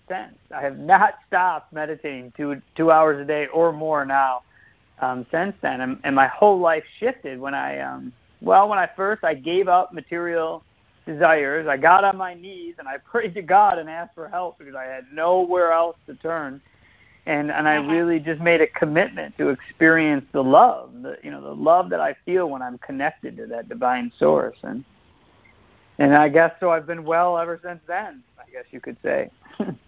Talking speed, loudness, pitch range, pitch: 200 wpm, -20 LUFS, 135-175 Hz, 160 Hz